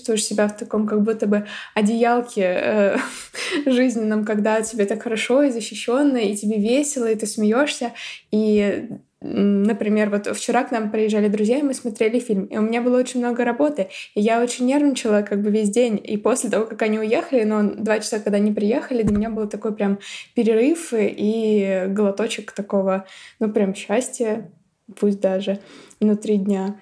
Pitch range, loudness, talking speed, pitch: 210-240 Hz, -21 LUFS, 170 wpm, 220 Hz